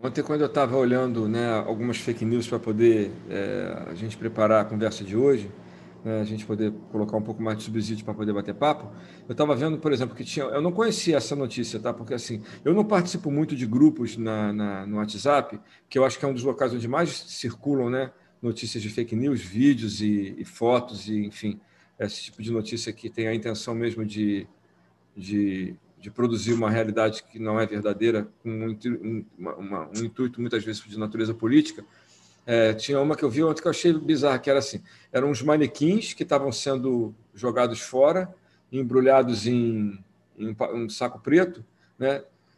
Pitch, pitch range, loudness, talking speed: 115 Hz, 110-135 Hz, -26 LUFS, 190 wpm